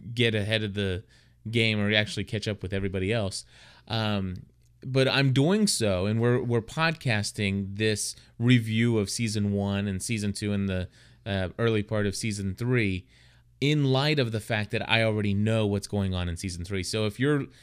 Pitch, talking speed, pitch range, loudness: 110 Hz, 185 wpm, 100-120 Hz, -27 LUFS